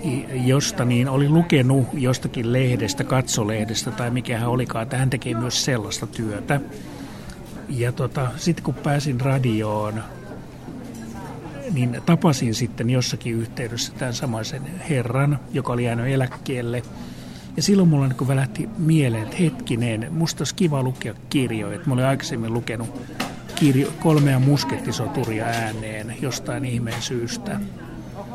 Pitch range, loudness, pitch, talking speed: 115-140 Hz, -22 LUFS, 125 Hz, 125 wpm